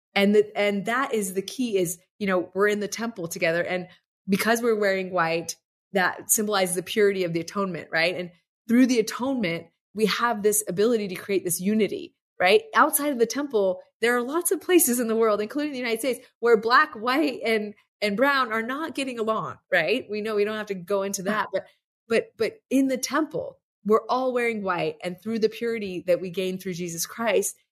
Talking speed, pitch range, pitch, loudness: 210 wpm, 190-245 Hz, 215 Hz, -24 LUFS